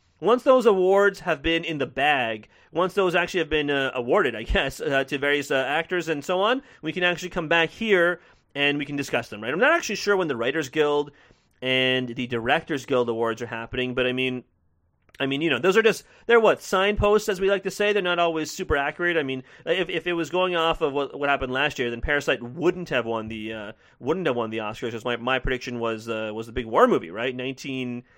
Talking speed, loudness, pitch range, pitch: 245 wpm, -24 LUFS, 125-175 Hz, 145 Hz